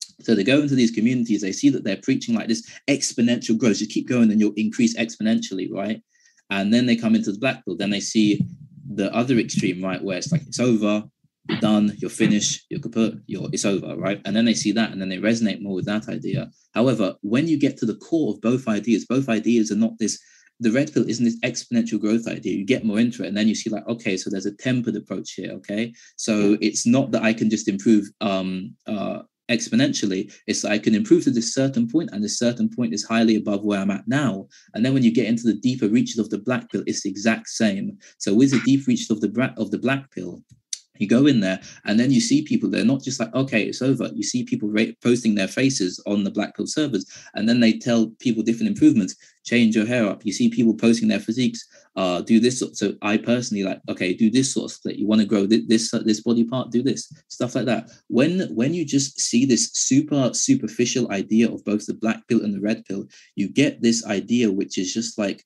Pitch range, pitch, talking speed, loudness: 105-130 Hz, 115 Hz, 240 wpm, -22 LUFS